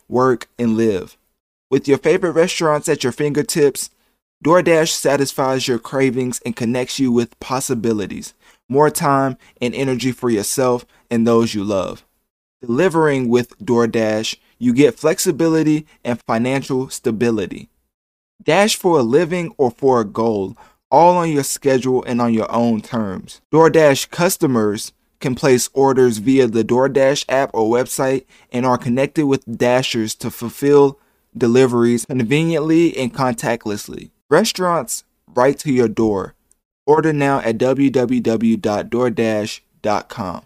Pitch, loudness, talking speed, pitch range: 130 Hz, -17 LUFS, 130 wpm, 115-145 Hz